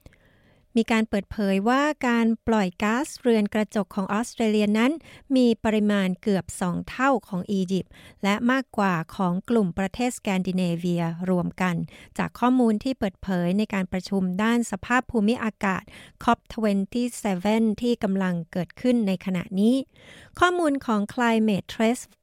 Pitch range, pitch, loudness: 190-235 Hz, 215 Hz, -24 LUFS